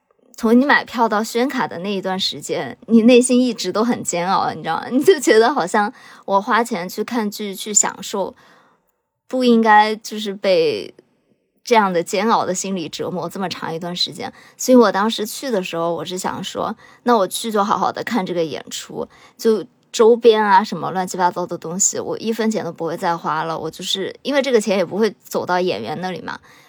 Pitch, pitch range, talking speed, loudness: 210 Hz, 180-240 Hz, 290 characters per minute, -18 LUFS